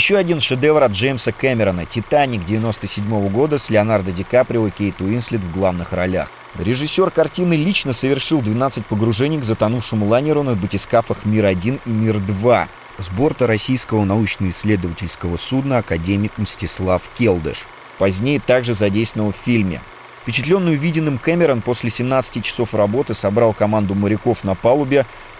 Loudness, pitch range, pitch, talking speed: -18 LUFS, 105-130 Hz, 115 Hz, 135 wpm